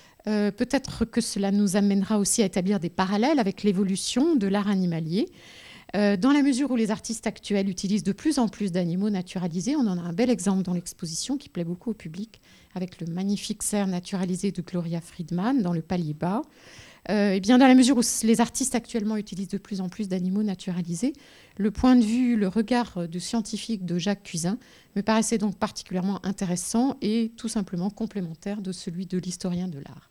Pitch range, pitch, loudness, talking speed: 185-225 Hz, 205 Hz, -26 LUFS, 195 wpm